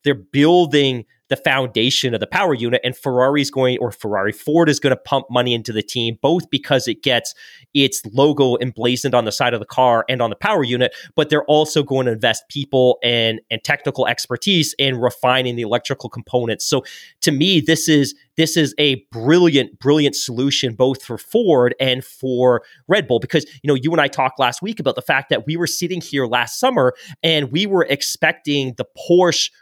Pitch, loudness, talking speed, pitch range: 130 Hz, -17 LUFS, 200 wpm, 125-150 Hz